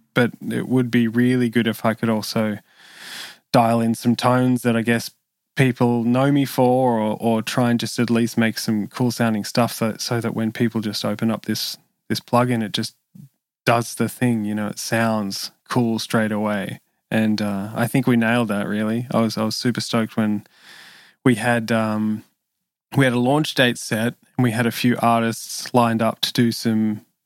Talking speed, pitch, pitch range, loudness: 200 wpm, 115 Hz, 110-120 Hz, -21 LUFS